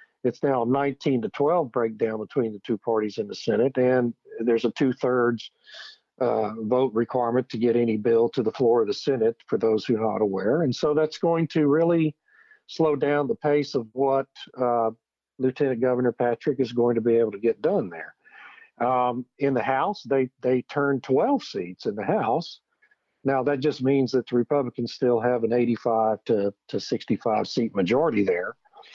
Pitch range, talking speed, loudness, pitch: 115-145 Hz, 190 wpm, -24 LUFS, 125 Hz